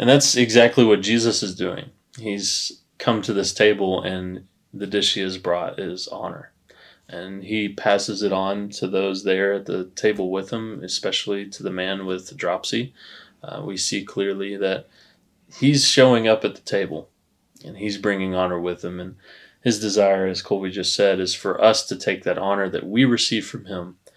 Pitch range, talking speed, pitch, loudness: 95-105 Hz, 190 wpm, 100 Hz, -21 LUFS